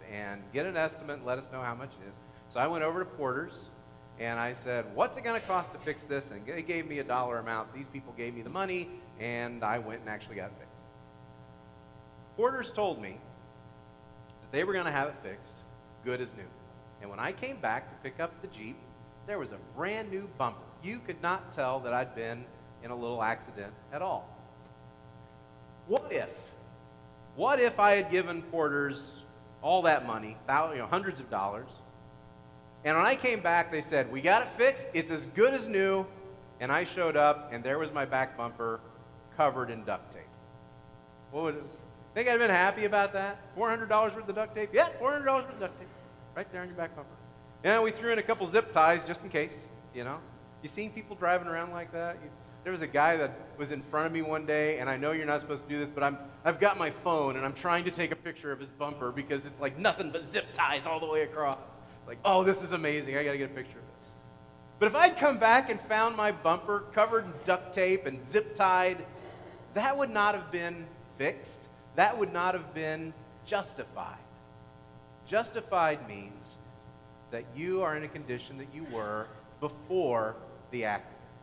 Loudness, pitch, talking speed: -31 LUFS, 145 Hz, 215 wpm